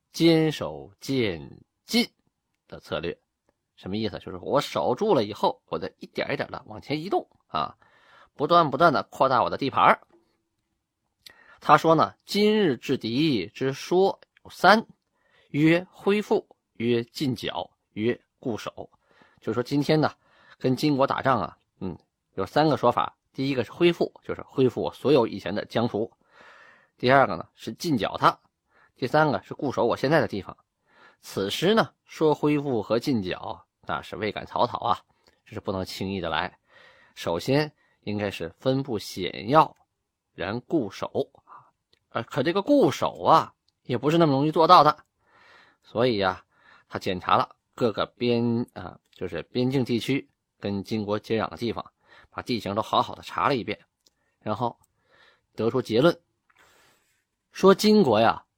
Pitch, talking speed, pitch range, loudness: 135 Hz, 220 characters per minute, 115-165 Hz, -25 LUFS